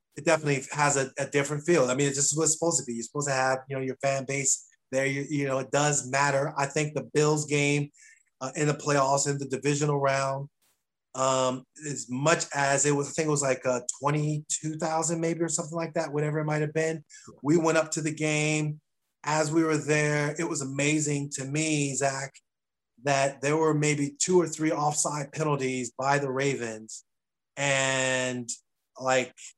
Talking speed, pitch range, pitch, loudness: 195 wpm, 135-155 Hz, 145 Hz, -27 LUFS